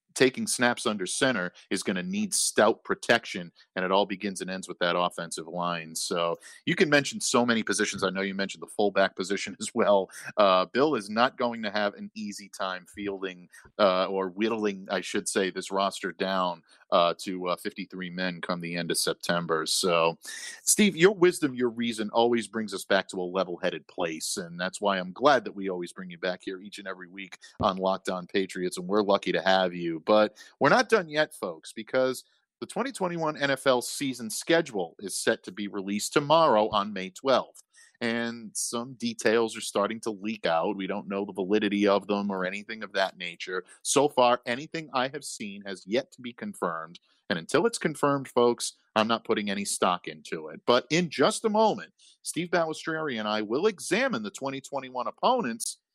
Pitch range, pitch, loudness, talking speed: 95-140 Hz, 105 Hz, -27 LUFS, 195 wpm